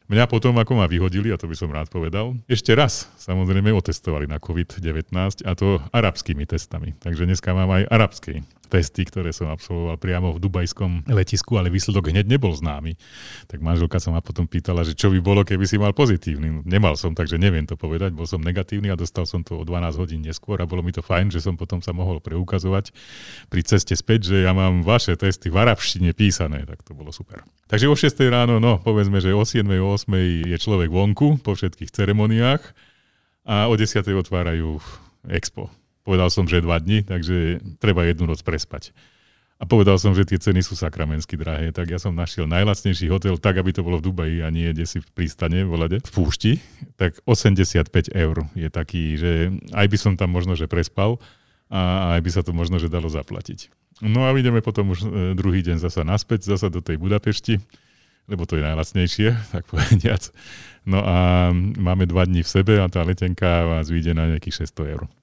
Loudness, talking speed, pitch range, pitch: -21 LUFS, 200 wpm, 85-100 Hz, 95 Hz